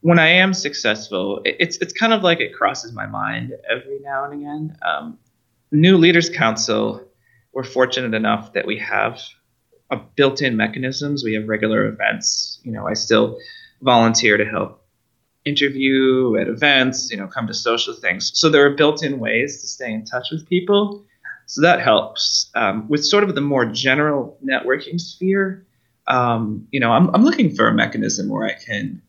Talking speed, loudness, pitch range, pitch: 175 wpm, -18 LUFS, 125-175 Hz, 140 Hz